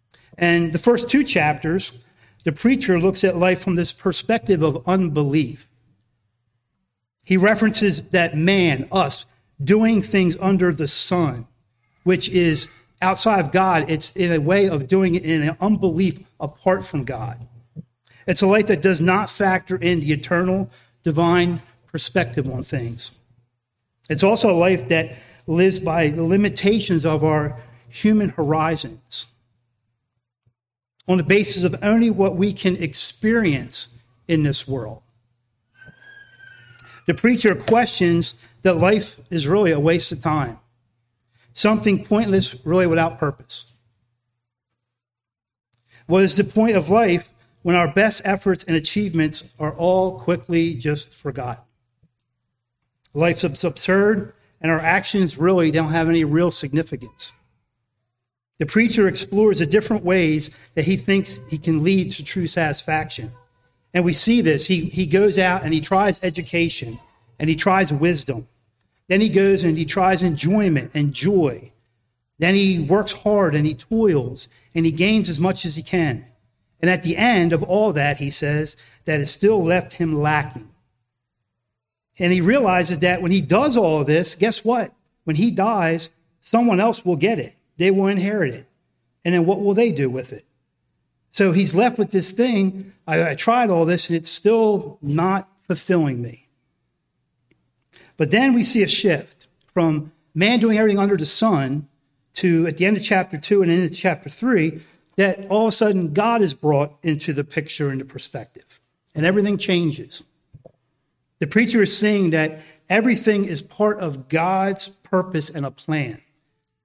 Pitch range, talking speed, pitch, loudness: 140-190 Hz, 155 wpm, 165 Hz, -19 LUFS